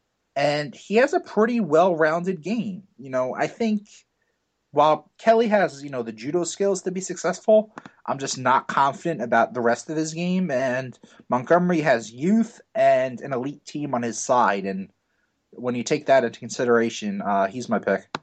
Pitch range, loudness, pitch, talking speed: 125-210 Hz, -23 LUFS, 165 Hz, 180 wpm